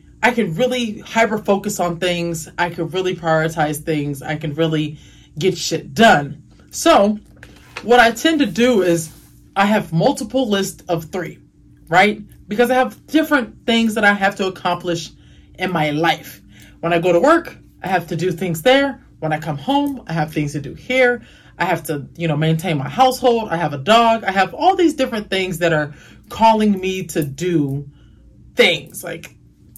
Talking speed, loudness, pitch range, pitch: 185 wpm, -17 LUFS, 160-230 Hz, 185 Hz